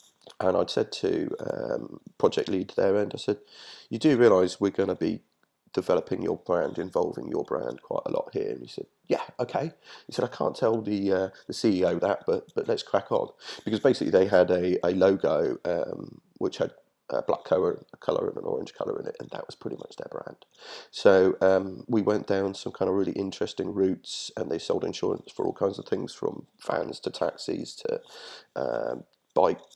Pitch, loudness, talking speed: 400 Hz, -27 LUFS, 205 wpm